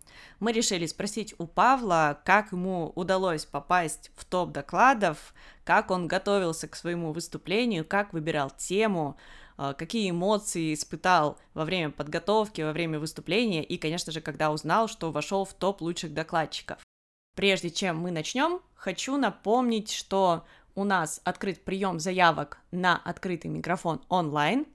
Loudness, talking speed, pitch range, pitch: -28 LUFS, 140 wpm, 160-200 Hz, 180 Hz